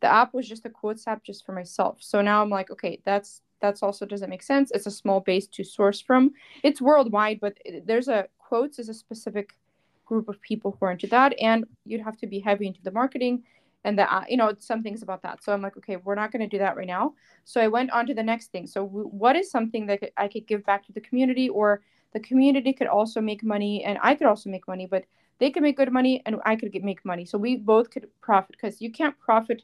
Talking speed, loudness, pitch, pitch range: 260 wpm, -25 LUFS, 215 Hz, 200-240 Hz